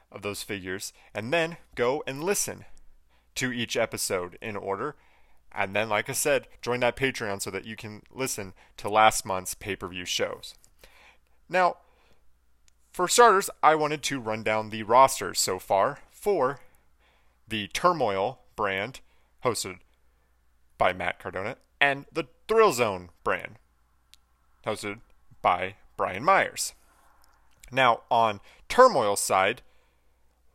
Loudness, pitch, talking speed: -26 LUFS, 105 Hz, 125 wpm